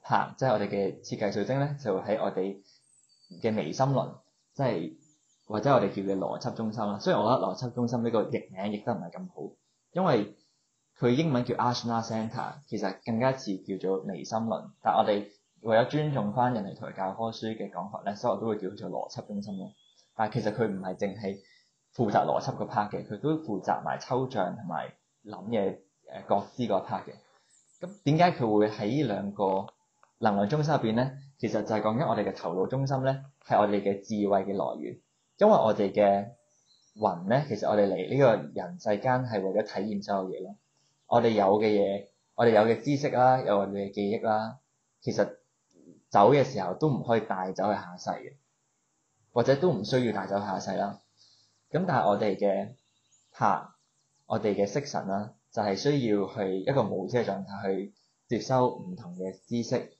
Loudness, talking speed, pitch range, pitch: -29 LUFS, 290 characters per minute, 100-125 Hz, 110 Hz